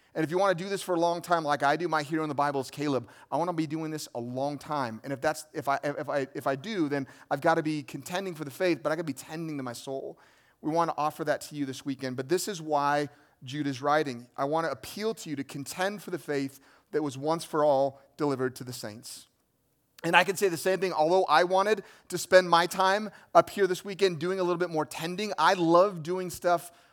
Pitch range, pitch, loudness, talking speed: 140-180 Hz, 155 Hz, -29 LUFS, 275 wpm